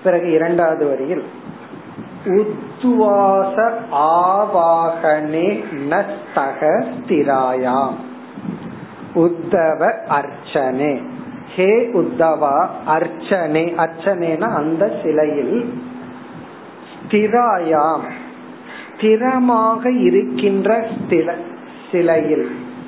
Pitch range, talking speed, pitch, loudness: 160-220 Hz, 50 wpm, 175 Hz, -17 LUFS